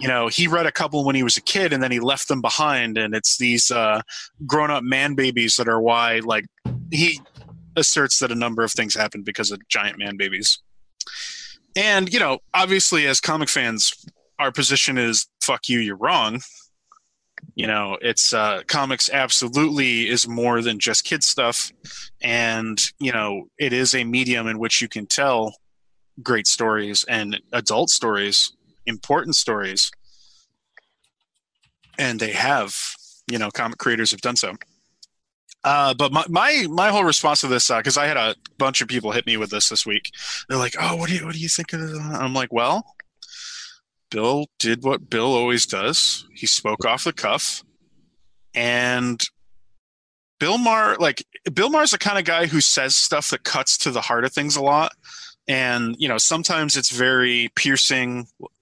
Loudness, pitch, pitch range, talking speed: -19 LUFS, 125 Hz, 115-150 Hz, 180 wpm